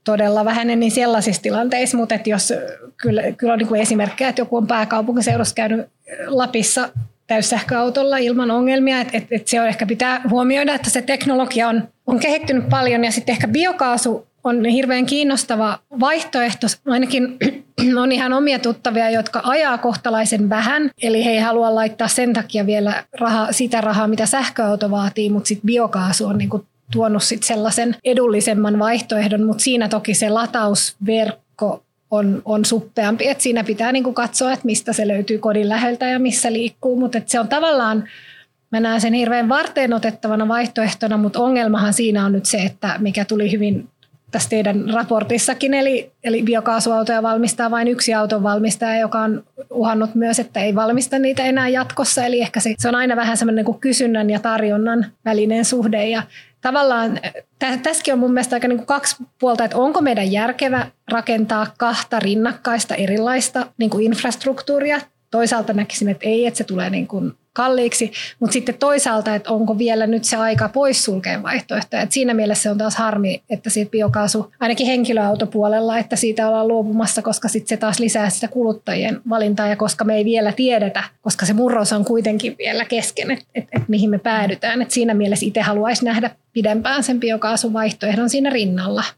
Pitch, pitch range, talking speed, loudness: 230 Hz, 215-245 Hz, 170 wpm, -18 LUFS